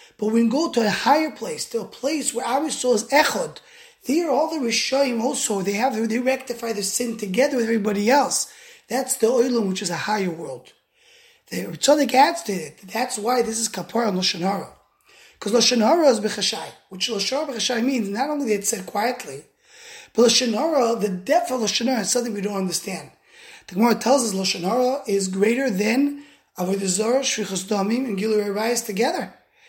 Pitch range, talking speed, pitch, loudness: 210-275 Hz, 185 wpm, 235 Hz, -21 LUFS